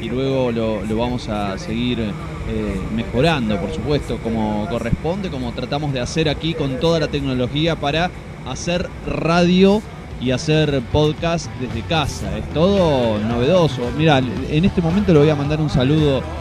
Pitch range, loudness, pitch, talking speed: 115-155 Hz, -19 LUFS, 135 Hz, 155 wpm